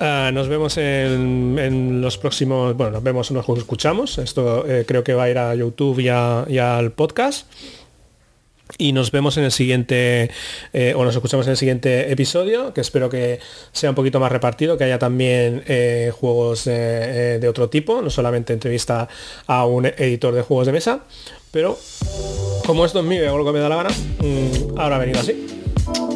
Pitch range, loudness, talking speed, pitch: 120-145 Hz, -19 LUFS, 195 wpm, 125 Hz